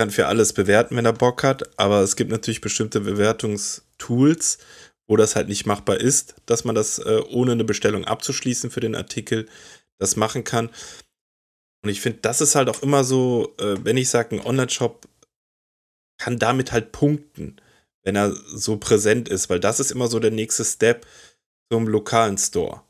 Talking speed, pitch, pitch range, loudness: 175 wpm, 115 Hz, 105-125 Hz, -21 LUFS